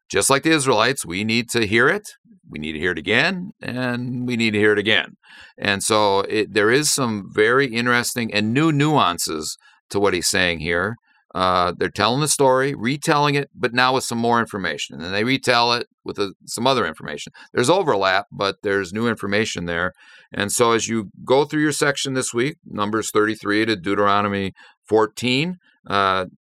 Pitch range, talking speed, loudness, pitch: 100-130 Hz, 190 wpm, -20 LUFS, 115 Hz